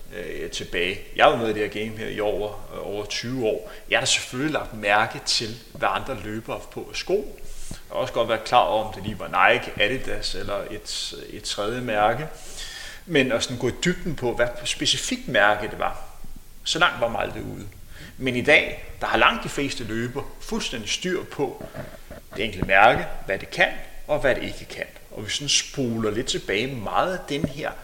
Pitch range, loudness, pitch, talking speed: 105-140 Hz, -24 LUFS, 120 Hz, 205 wpm